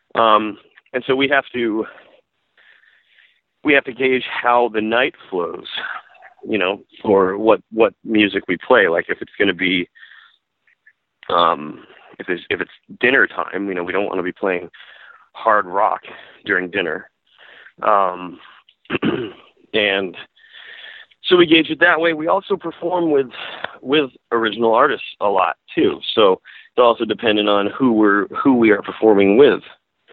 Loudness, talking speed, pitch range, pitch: -17 LUFS, 155 wpm, 105-170 Hz, 120 Hz